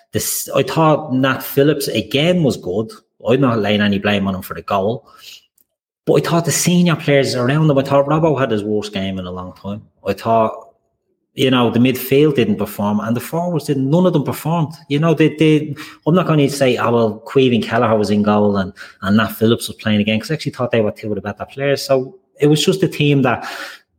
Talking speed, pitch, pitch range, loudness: 235 wpm, 130 Hz, 110-150 Hz, -16 LUFS